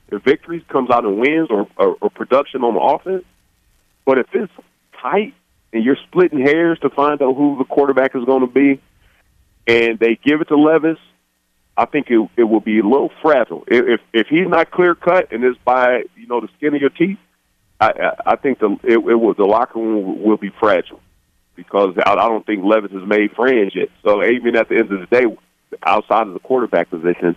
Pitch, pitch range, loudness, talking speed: 125 Hz, 110-155 Hz, -16 LUFS, 220 wpm